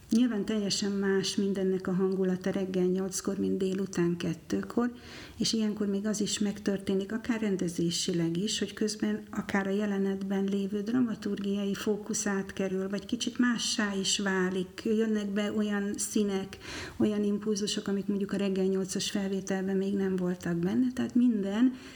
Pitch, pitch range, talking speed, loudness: 200 Hz, 190-210 Hz, 140 wpm, -30 LUFS